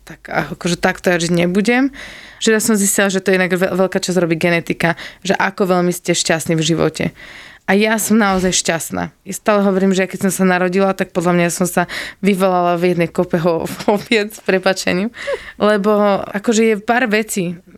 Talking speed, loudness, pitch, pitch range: 190 wpm, -16 LUFS, 190 Hz, 180-205 Hz